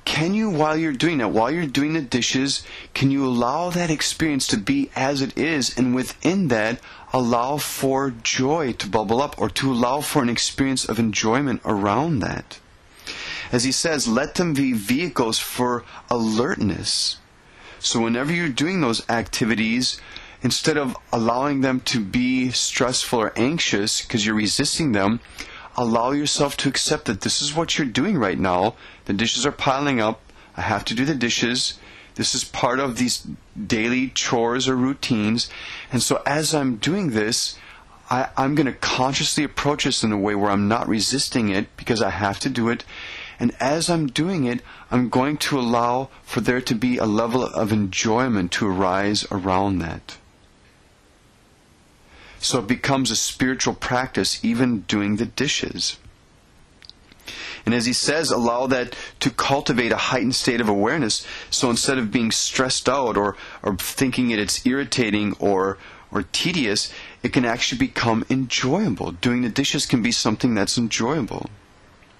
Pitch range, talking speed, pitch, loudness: 110-140 Hz, 165 wpm, 125 Hz, -21 LUFS